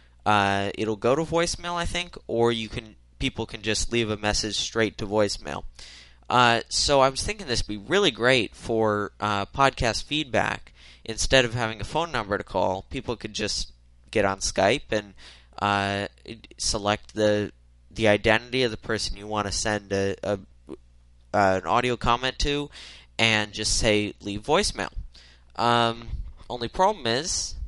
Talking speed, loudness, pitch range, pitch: 165 wpm, -25 LUFS, 95-115 Hz, 105 Hz